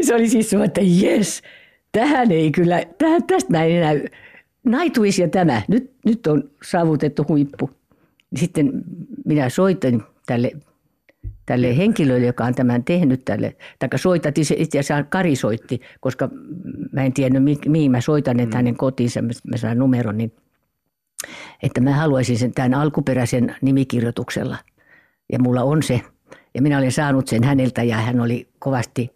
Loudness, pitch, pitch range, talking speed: -19 LUFS, 140 Hz, 125-175 Hz, 150 wpm